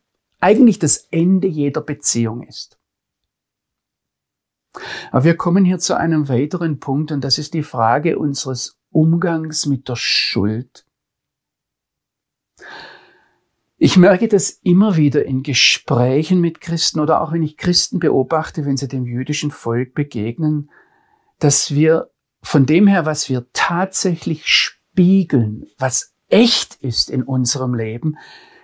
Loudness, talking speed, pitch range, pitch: -16 LUFS, 125 wpm, 130-175 Hz, 155 Hz